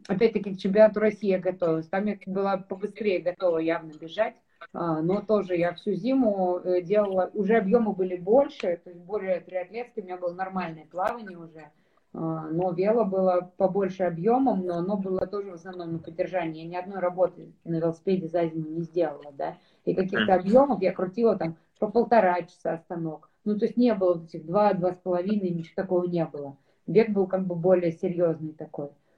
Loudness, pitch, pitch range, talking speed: -26 LUFS, 185 Hz, 170-205 Hz, 180 wpm